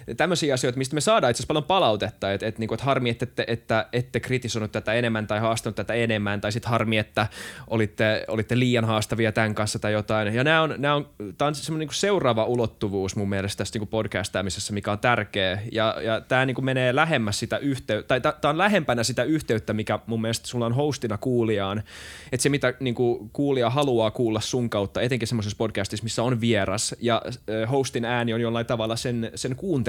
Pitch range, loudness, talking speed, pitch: 110-130 Hz, -24 LUFS, 195 wpm, 115 Hz